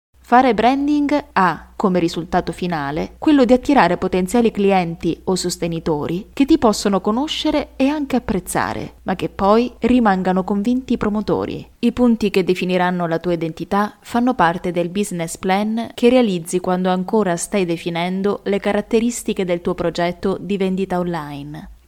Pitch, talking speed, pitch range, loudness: 195 Hz, 145 wpm, 175-235 Hz, -18 LUFS